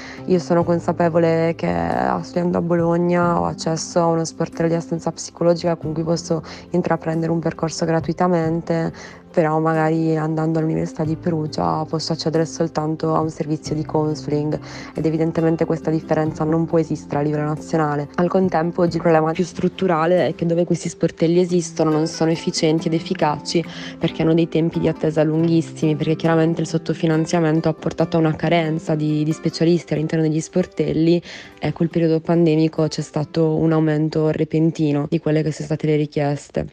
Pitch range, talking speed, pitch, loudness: 155-170 Hz, 165 wpm, 160 Hz, -20 LUFS